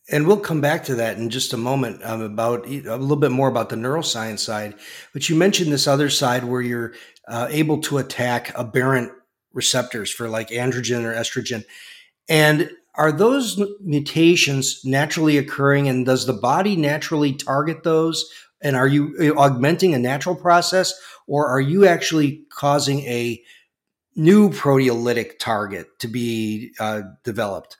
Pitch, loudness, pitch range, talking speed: 140 Hz, -20 LUFS, 120-155 Hz, 155 wpm